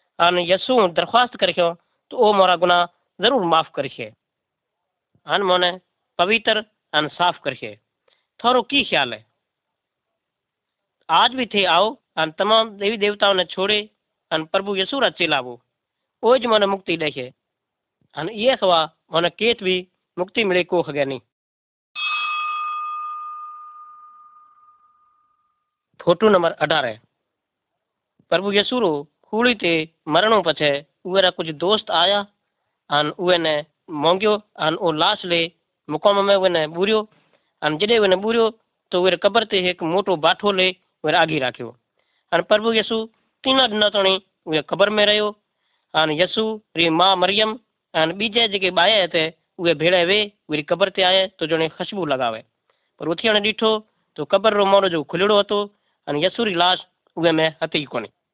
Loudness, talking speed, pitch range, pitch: -19 LUFS, 140 wpm, 165-220 Hz, 190 Hz